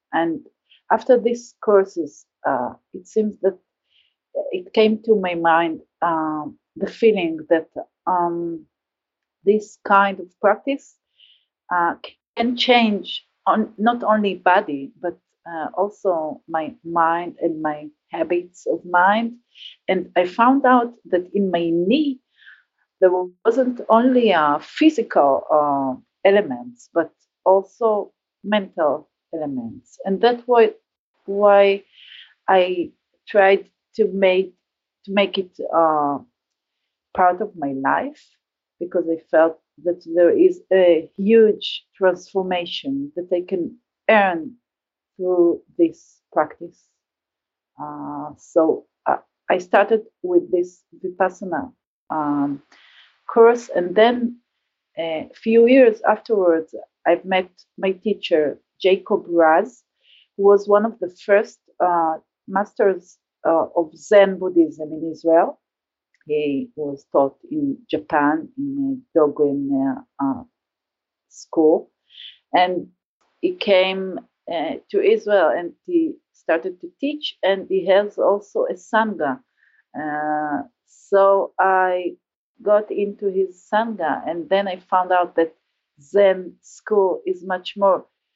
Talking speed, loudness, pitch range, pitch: 115 wpm, -20 LUFS, 170-225 Hz, 190 Hz